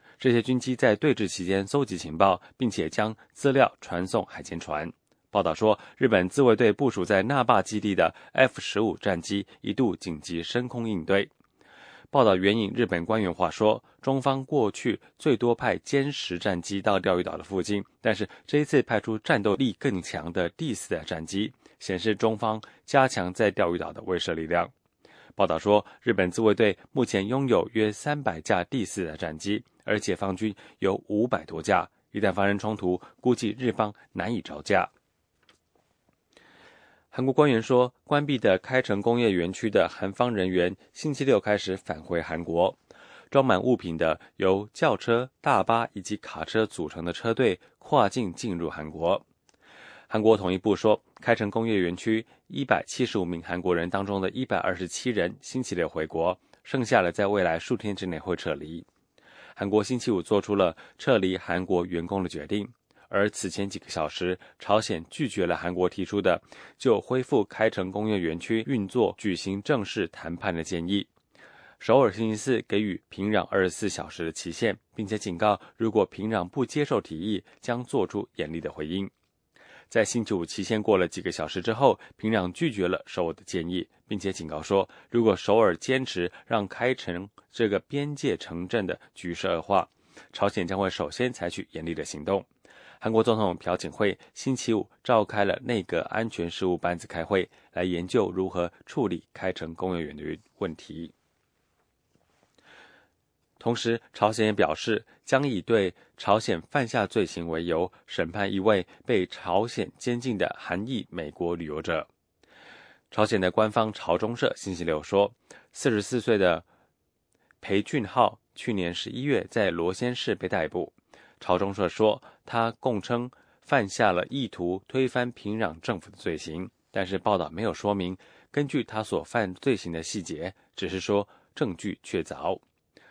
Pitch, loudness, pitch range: 100 Hz, -27 LUFS, 90-115 Hz